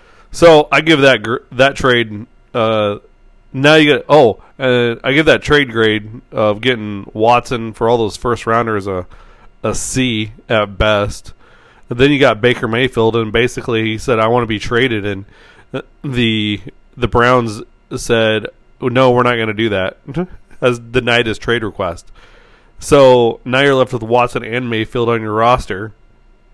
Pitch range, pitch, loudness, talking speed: 110-130 Hz, 120 Hz, -14 LUFS, 165 wpm